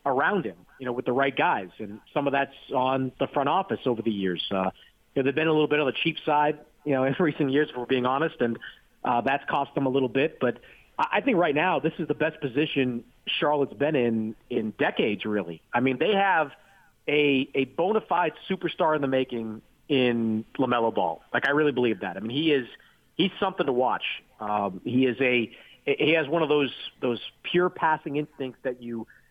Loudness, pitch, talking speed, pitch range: -26 LUFS, 135 Hz, 220 wpm, 120-150 Hz